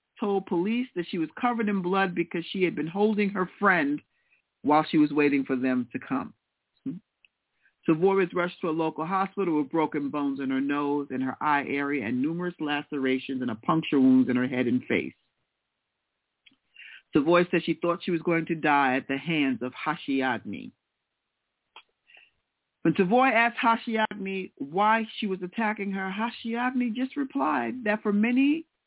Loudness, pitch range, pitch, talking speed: -26 LUFS, 145-210 Hz, 175 Hz, 170 wpm